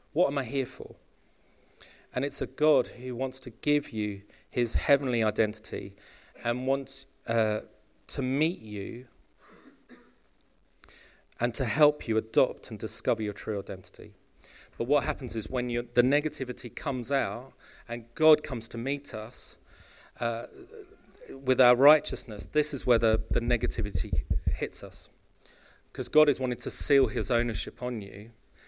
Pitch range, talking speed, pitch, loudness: 115-140 Hz, 145 wpm, 125 Hz, -29 LUFS